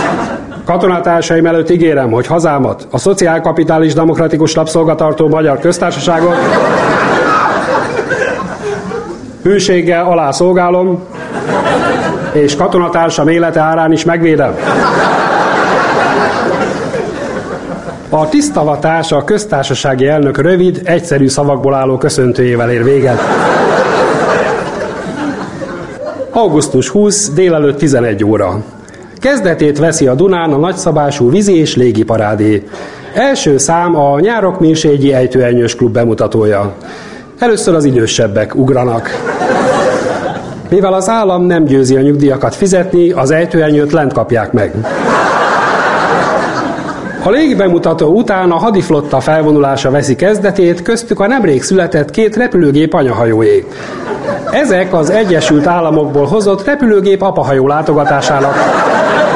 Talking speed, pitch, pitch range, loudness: 95 wpm, 160 Hz, 135-180 Hz, -10 LUFS